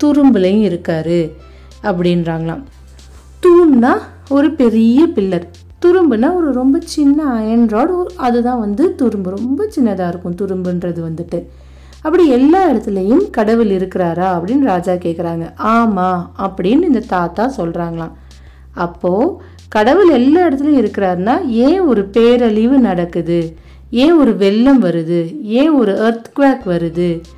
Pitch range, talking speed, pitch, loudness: 175-270 Hz, 105 wpm, 215 Hz, -13 LUFS